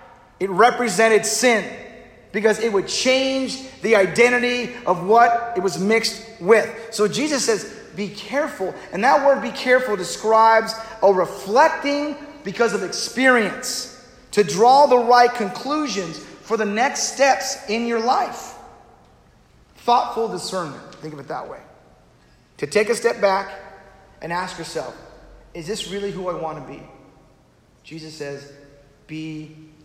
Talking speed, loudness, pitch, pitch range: 140 wpm, -19 LUFS, 220 Hz, 180-245 Hz